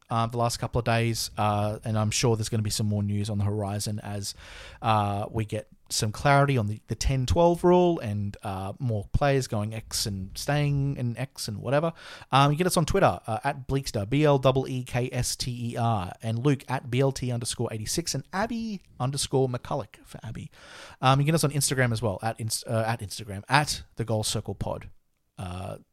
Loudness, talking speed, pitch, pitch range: -27 LUFS, 210 wpm, 115 Hz, 105-135 Hz